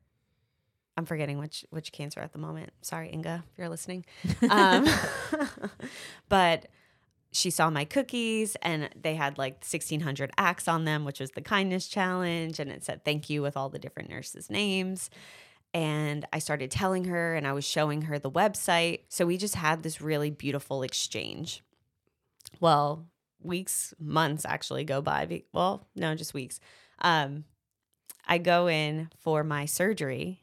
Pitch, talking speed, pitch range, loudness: 160 Hz, 160 wpm, 145-175 Hz, -29 LUFS